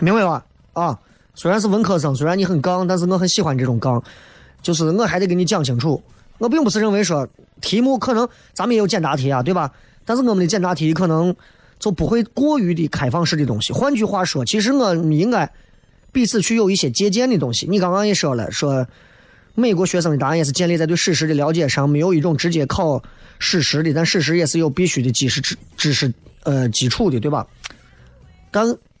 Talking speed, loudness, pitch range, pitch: 320 characters per minute, -18 LUFS, 145-205 Hz, 170 Hz